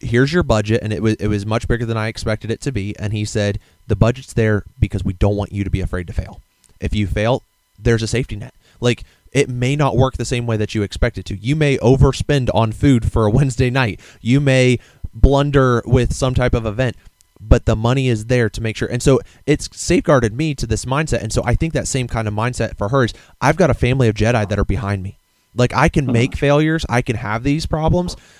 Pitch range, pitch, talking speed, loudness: 105-130 Hz, 115 Hz, 245 wpm, -18 LUFS